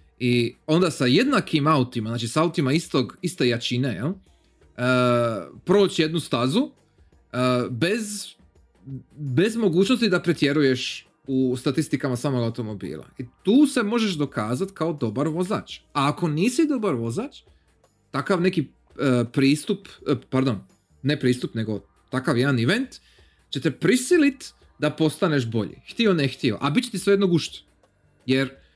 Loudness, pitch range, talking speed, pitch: -23 LUFS, 120-175 Hz, 145 wpm, 135 Hz